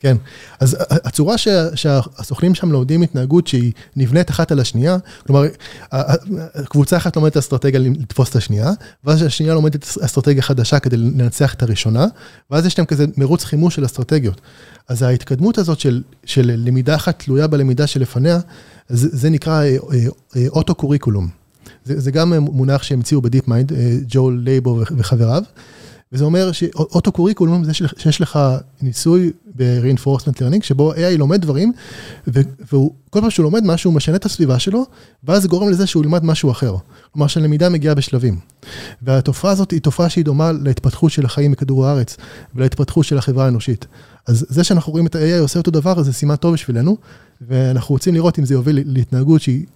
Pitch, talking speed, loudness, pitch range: 145 Hz, 160 wpm, -16 LUFS, 130-165 Hz